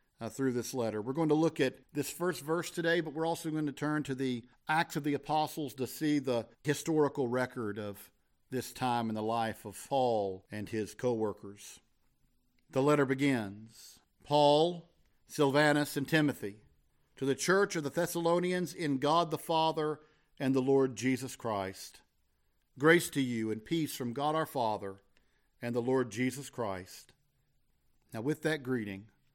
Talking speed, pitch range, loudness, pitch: 170 wpm, 115-155 Hz, -32 LUFS, 135 Hz